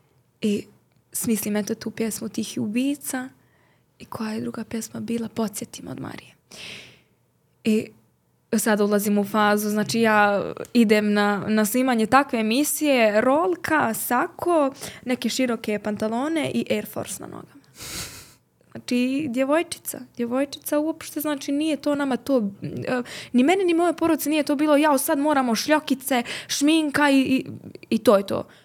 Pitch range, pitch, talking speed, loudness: 220-290 Hz, 245 Hz, 140 wpm, -23 LUFS